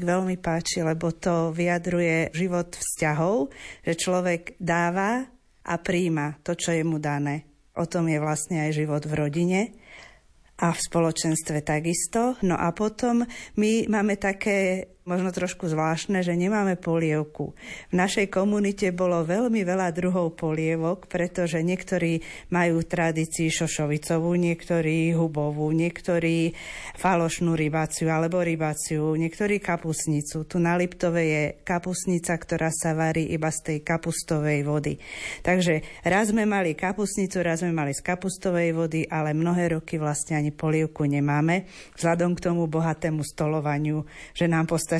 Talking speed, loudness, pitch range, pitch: 135 wpm, -25 LUFS, 160-180 Hz, 170 Hz